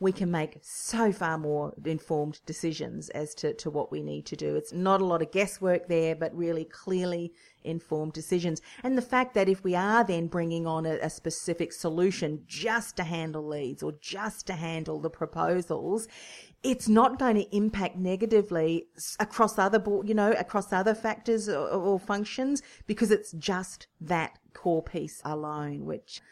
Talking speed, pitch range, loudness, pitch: 175 wpm, 160-210 Hz, -29 LUFS, 175 Hz